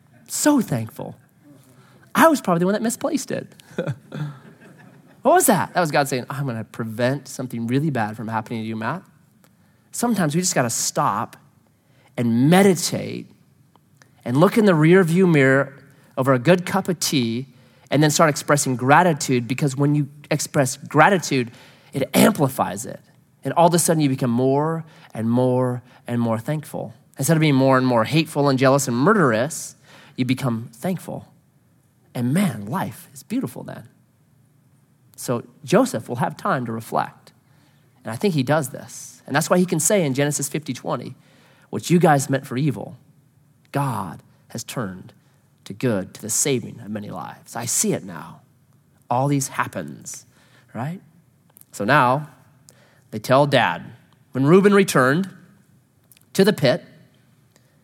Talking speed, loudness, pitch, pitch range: 160 wpm, -20 LUFS, 140 Hz, 130-160 Hz